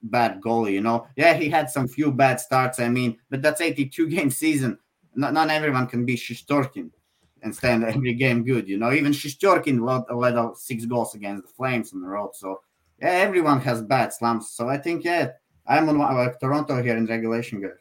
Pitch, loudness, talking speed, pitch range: 125 Hz, -23 LUFS, 210 wpm, 115-145 Hz